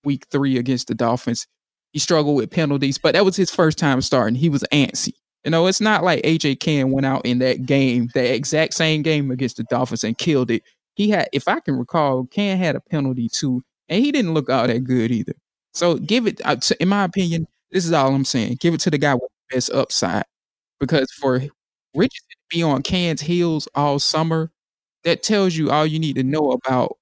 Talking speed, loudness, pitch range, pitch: 220 wpm, -19 LUFS, 130-170 Hz, 145 Hz